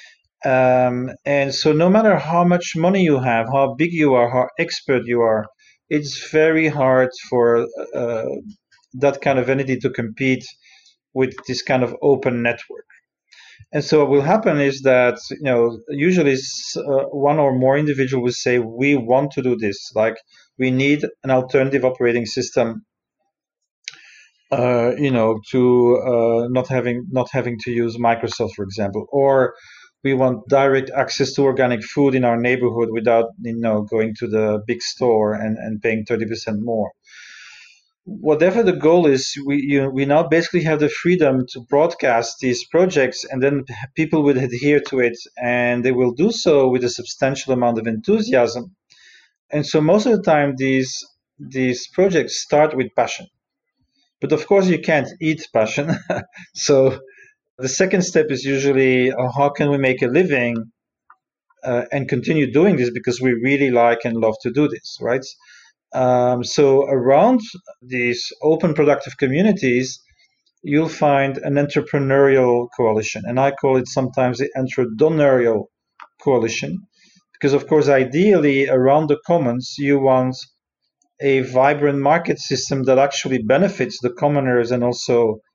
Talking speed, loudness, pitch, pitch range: 155 wpm, -18 LUFS, 135 Hz, 120-145 Hz